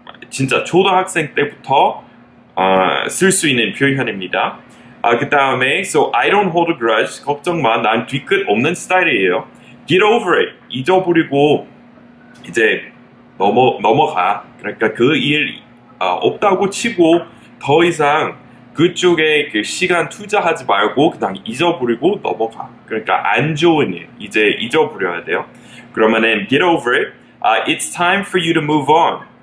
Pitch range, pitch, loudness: 120-180 Hz, 155 Hz, -15 LUFS